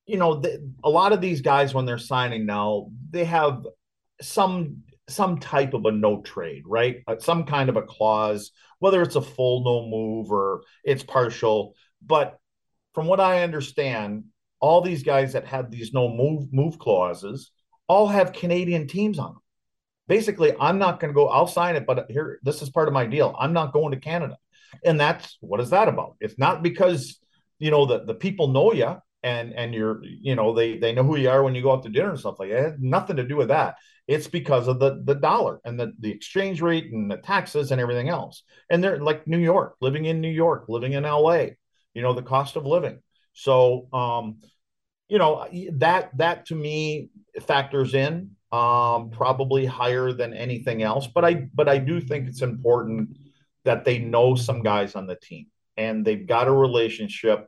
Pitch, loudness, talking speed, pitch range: 135 Hz, -23 LUFS, 205 wpm, 120-170 Hz